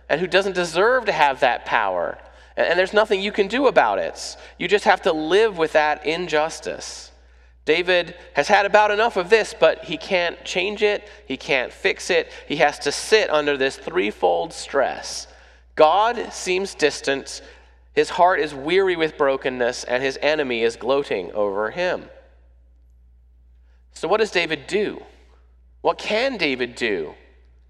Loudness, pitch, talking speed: -20 LUFS, 155 Hz, 160 wpm